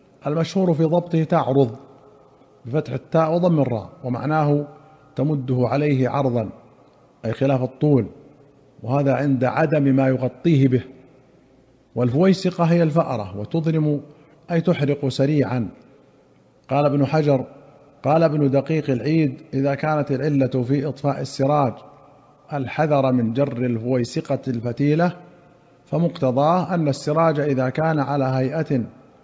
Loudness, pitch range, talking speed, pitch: -21 LUFS, 130-155 Hz, 110 wpm, 140 Hz